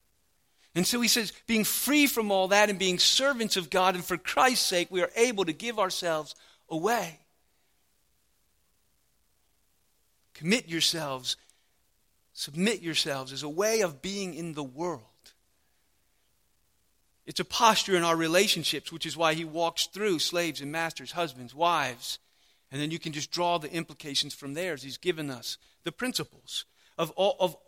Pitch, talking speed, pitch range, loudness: 170 Hz, 155 wpm, 150-190 Hz, -28 LUFS